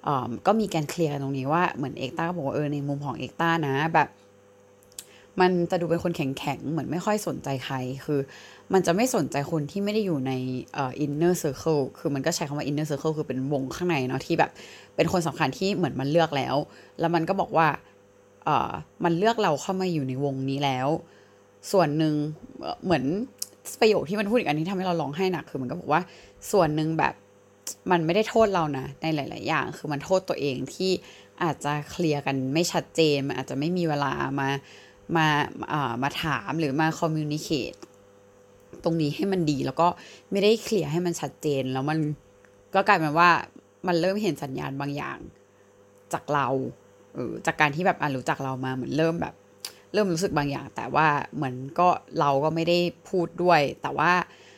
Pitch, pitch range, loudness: 150 Hz, 135-170 Hz, -26 LUFS